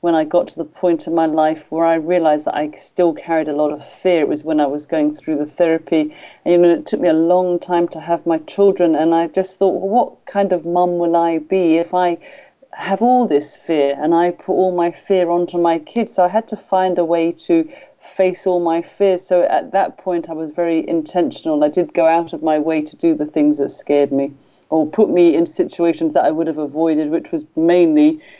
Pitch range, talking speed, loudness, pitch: 160-185 Hz, 245 wpm, -17 LUFS, 170 Hz